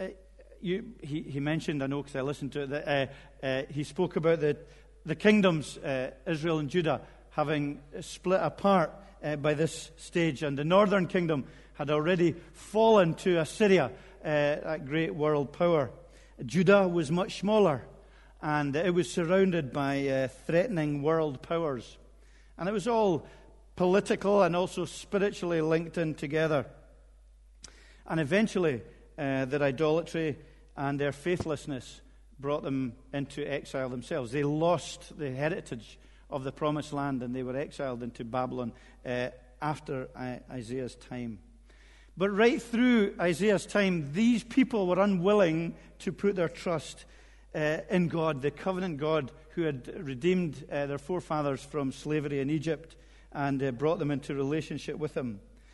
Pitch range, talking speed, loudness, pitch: 140-180 Hz, 150 wpm, -30 LUFS, 155 Hz